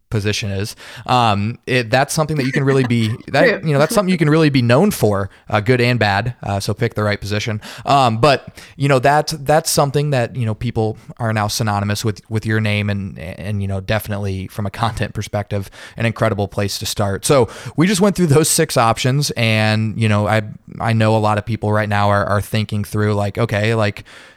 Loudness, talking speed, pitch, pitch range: -17 LUFS, 225 wpm, 110 Hz, 105-130 Hz